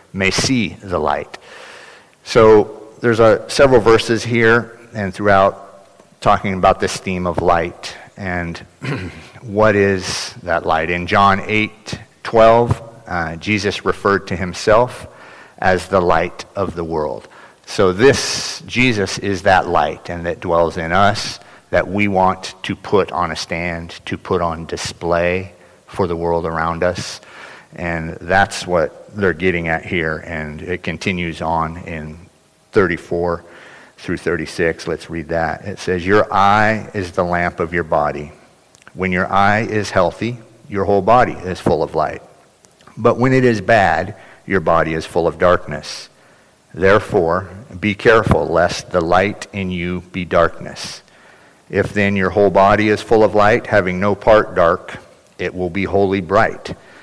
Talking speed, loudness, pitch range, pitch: 155 wpm, -16 LUFS, 85-105 Hz, 95 Hz